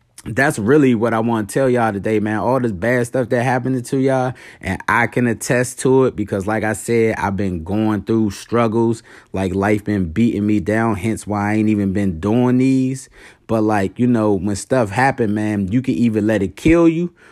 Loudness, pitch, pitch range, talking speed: -17 LUFS, 115 Hz, 105-125 Hz, 215 wpm